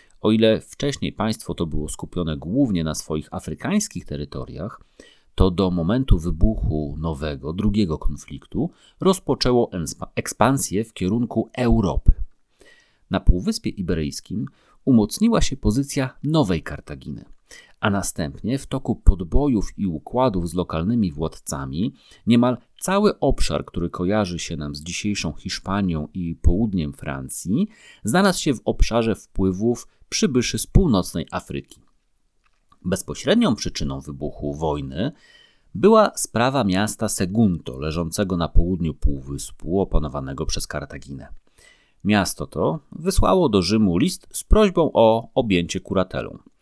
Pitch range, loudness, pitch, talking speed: 80-115 Hz, -22 LUFS, 95 Hz, 115 wpm